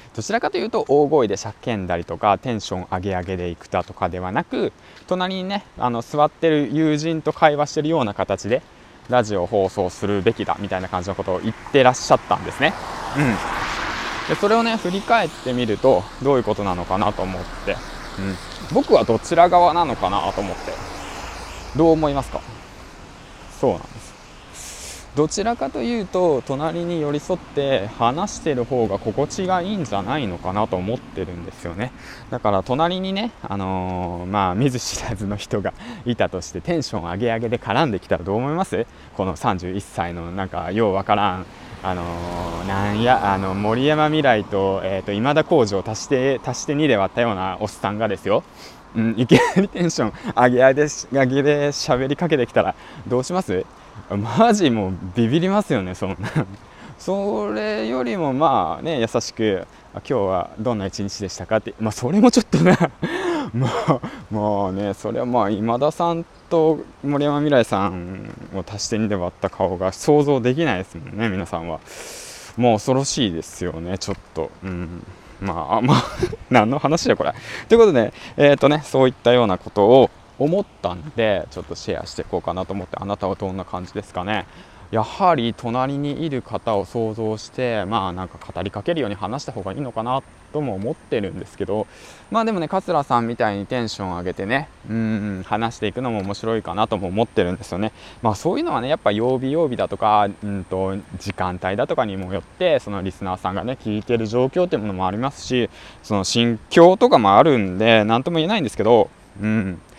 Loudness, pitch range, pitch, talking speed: -21 LUFS, 95-140 Hz, 110 Hz, 370 characters per minute